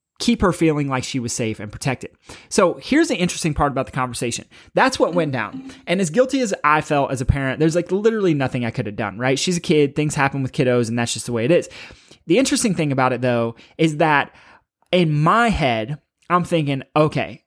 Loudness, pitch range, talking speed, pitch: -20 LUFS, 125-175 Hz, 230 wpm, 150 Hz